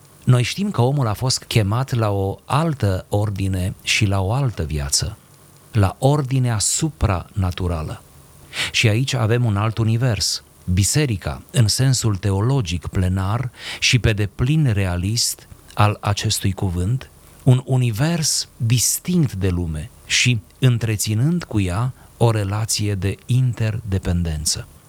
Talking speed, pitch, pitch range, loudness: 120 wpm, 110 Hz, 95-125 Hz, -20 LUFS